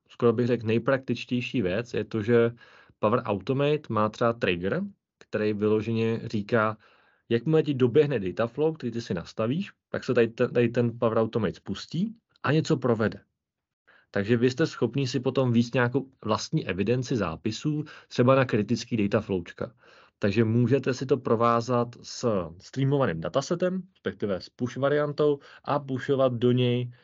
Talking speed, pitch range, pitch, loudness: 155 wpm, 115-140 Hz, 125 Hz, -27 LUFS